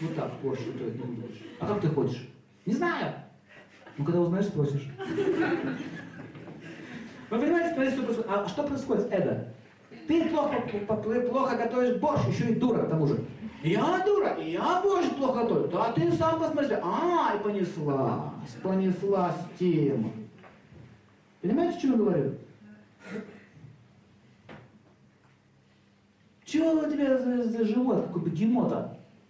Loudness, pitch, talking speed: -28 LUFS, 215 Hz, 135 wpm